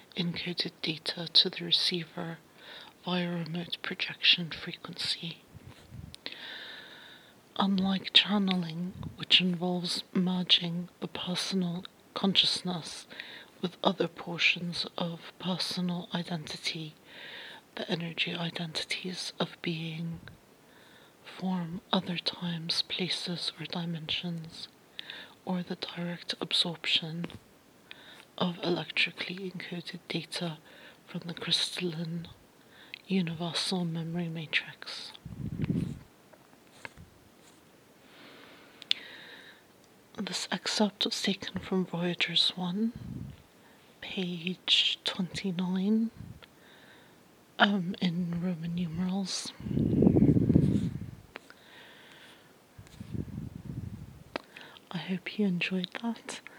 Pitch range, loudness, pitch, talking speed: 170-185 Hz, -30 LUFS, 180 Hz, 70 wpm